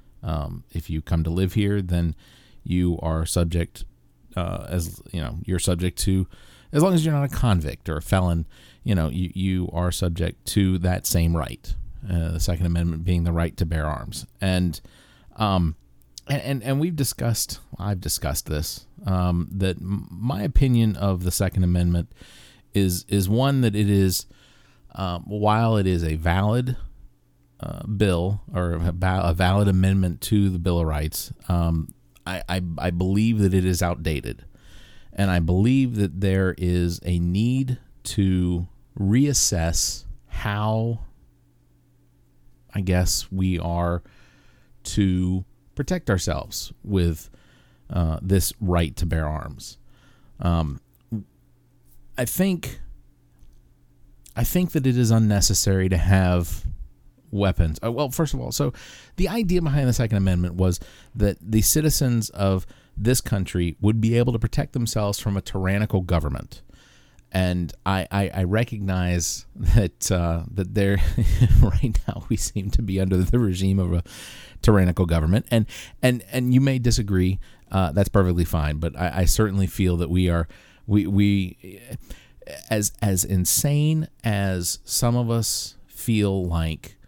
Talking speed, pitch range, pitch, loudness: 145 wpm, 85-110 Hz, 95 Hz, -23 LUFS